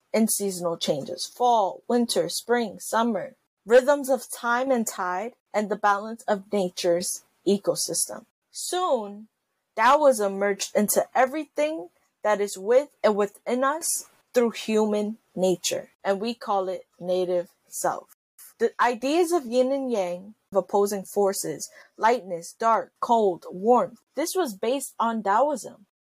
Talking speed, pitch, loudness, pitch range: 130 wpm, 225 Hz, -25 LUFS, 195-255 Hz